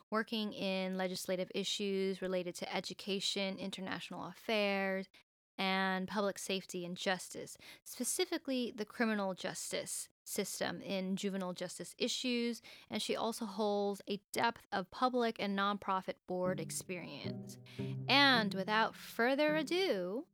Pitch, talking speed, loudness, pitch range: 195 Hz, 115 wpm, -37 LUFS, 185-225 Hz